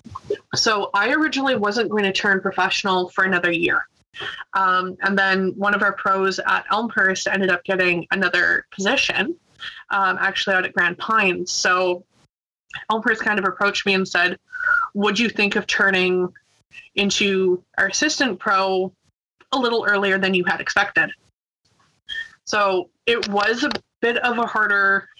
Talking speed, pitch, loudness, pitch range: 150 wpm, 195 Hz, -19 LUFS, 190-225 Hz